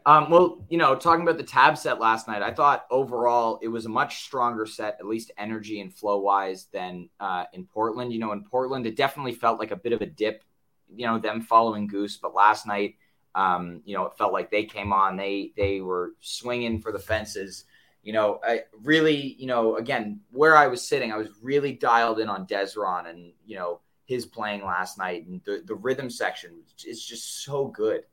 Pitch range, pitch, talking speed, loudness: 100-130 Hz, 110 Hz, 215 wpm, -25 LUFS